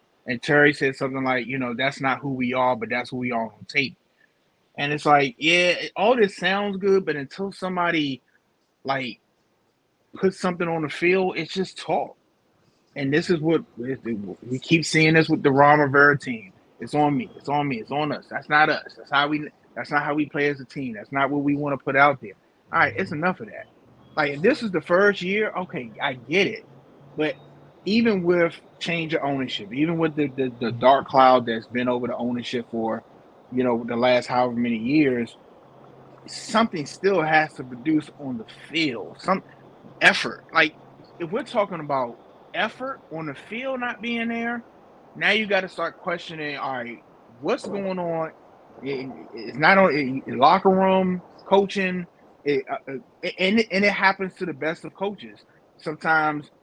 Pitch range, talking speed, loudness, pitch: 135-190 Hz, 190 wpm, -23 LUFS, 155 Hz